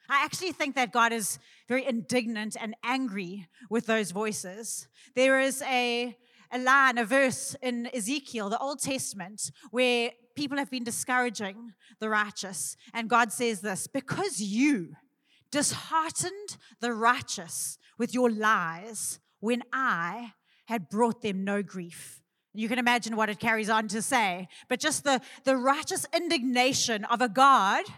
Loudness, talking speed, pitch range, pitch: -28 LUFS, 150 wpm, 215-260 Hz, 235 Hz